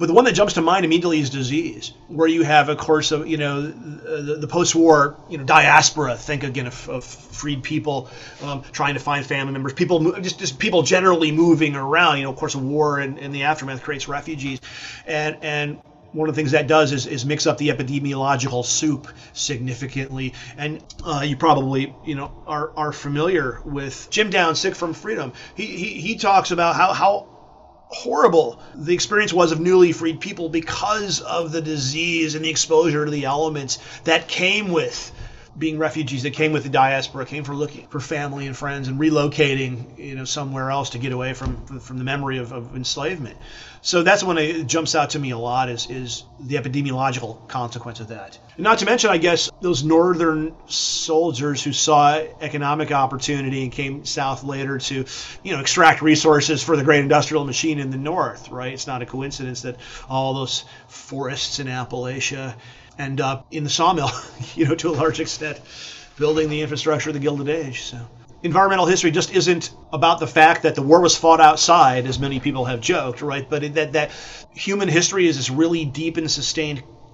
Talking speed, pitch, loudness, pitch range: 195 wpm, 150 Hz, -20 LUFS, 135-160 Hz